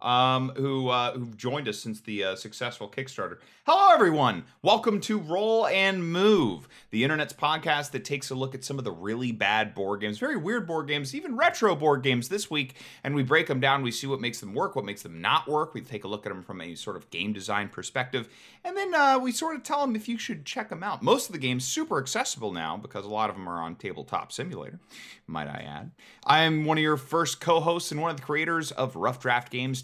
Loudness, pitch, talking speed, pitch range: -27 LUFS, 135 Hz, 240 wpm, 120-170 Hz